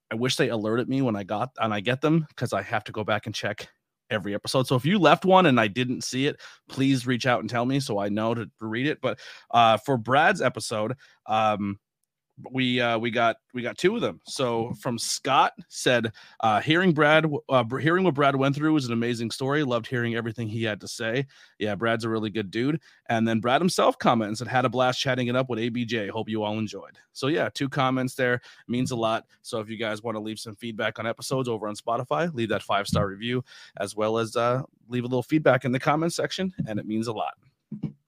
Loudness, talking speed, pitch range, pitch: -25 LUFS, 240 wpm, 110-130 Hz, 120 Hz